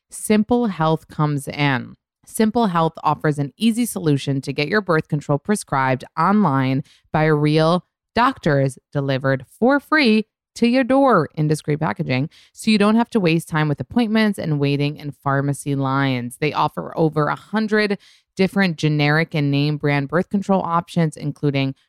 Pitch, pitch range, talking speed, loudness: 155 Hz, 145-205 Hz, 155 wpm, -19 LUFS